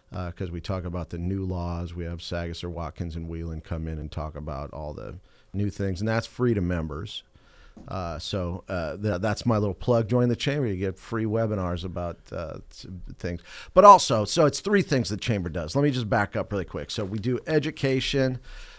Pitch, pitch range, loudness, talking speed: 95 Hz, 85-115 Hz, -26 LUFS, 215 wpm